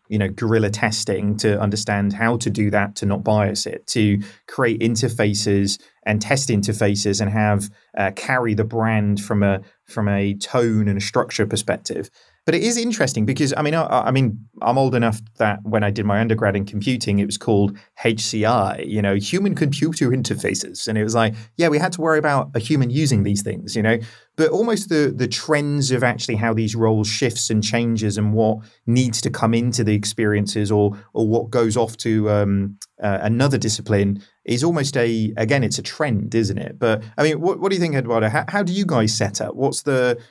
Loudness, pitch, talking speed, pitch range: -20 LUFS, 110 Hz, 210 wpm, 105-125 Hz